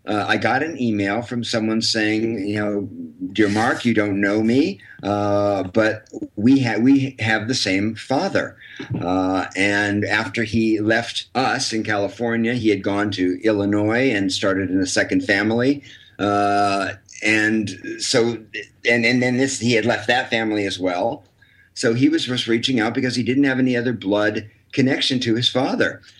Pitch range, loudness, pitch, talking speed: 100-125 Hz, -20 LUFS, 110 Hz, 170 wpm